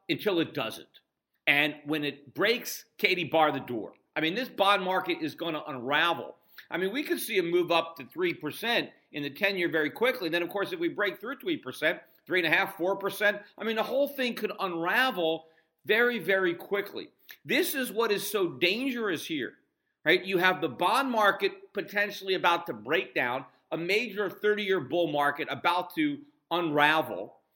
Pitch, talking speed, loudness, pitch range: 190 Hz, 180 wpm, -28 LUFS, 165-225 Hz